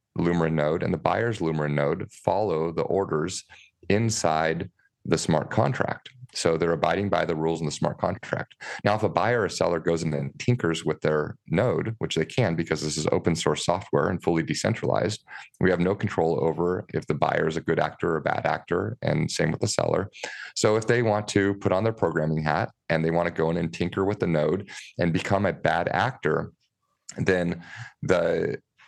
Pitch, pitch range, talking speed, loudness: 85 Hz, 80-100 Hz, 205 wpm, -25 LUFS